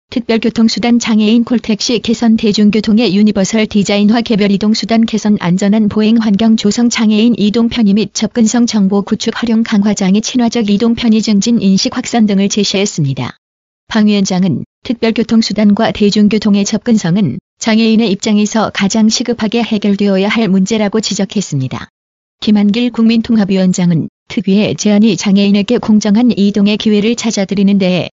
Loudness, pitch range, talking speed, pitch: -11 LUFS, 200-225 Hz, 375 characters per minute, 215 Hz